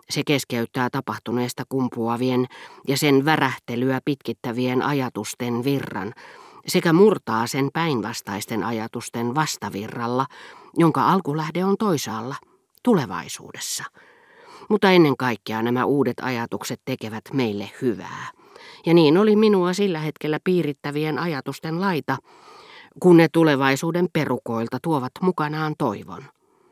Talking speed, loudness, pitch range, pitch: 105 wpm, -22 LUFS, 120-165 Hz, 135 Hz